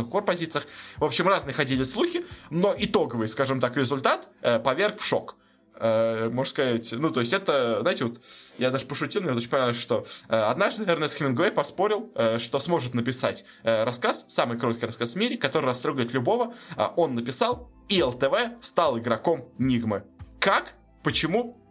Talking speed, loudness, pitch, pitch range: 170 wpm, -25 LUFS, 140 Hz, 120-175 Hz